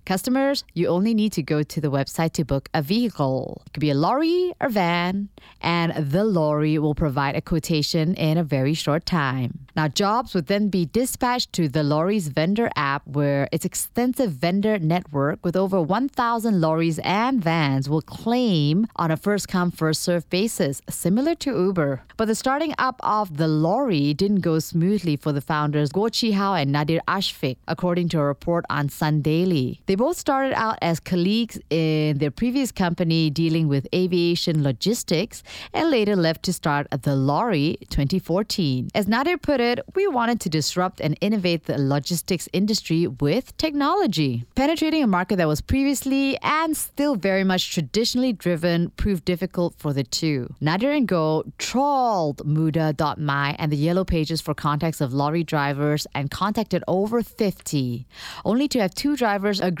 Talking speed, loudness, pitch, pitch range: 170 wpm, -22 LUFS, 175 Hz, 155-215 Hz